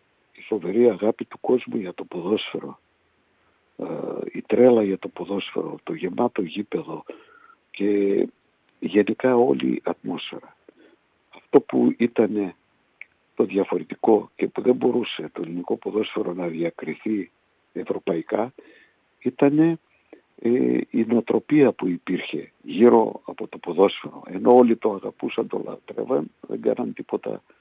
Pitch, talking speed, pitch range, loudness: 110 Hz, 115 wpm, 90-120 Hz, -23 LUFS